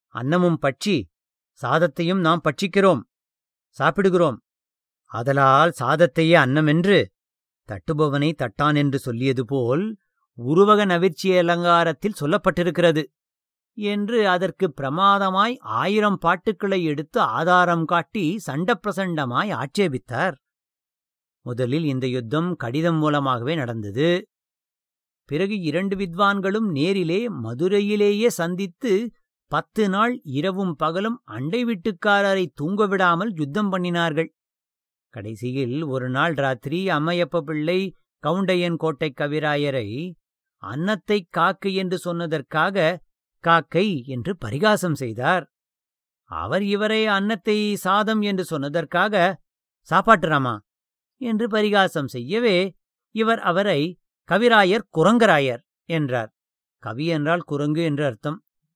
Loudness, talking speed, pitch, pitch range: -21 LUFS, 85 wpm, 170 Hz, 145-195 Hz